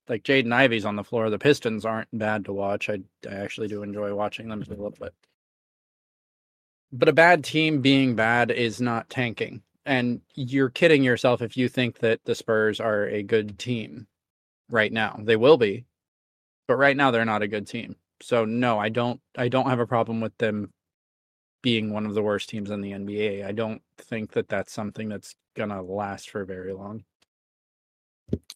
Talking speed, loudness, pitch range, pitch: 190 wpm, -24 LUFS, 100-120 Hz, 110 Hz